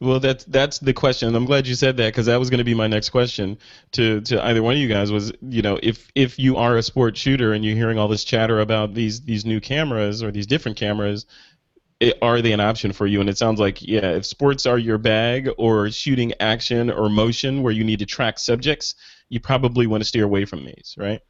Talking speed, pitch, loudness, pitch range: 250 wpm, 115 Hz, -20 LUFS, 105-125 Hz